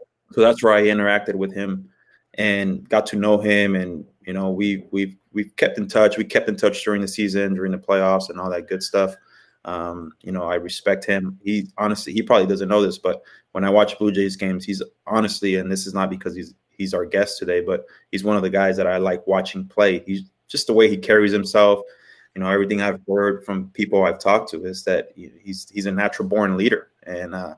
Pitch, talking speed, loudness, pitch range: 100 Hz, 235 wpm, -20 LUFS, 95-105 Hz